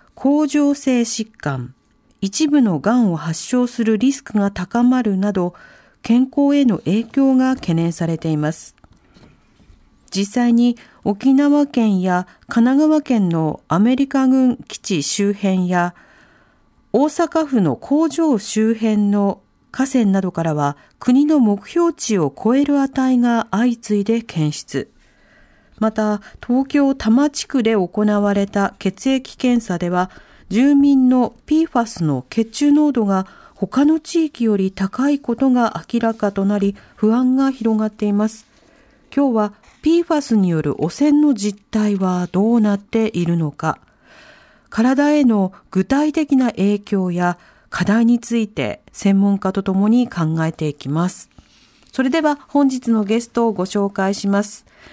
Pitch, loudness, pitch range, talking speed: 225 Hz, -18 LUFS, 195-265 Hz, 245 characters per minute